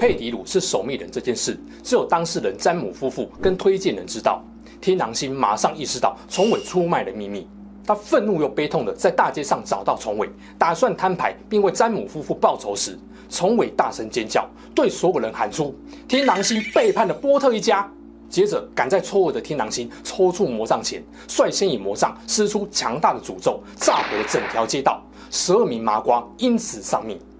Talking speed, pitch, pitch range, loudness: 290 characters per minute, 205 Hz, 170-240 Hz, -21 LUFS